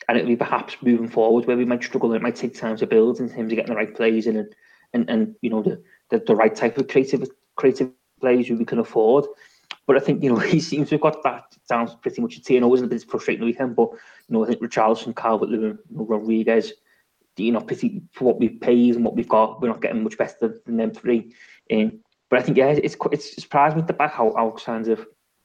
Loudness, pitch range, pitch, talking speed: -21 LUFS, 115-145 Hz, 120 Hz, 260 wpm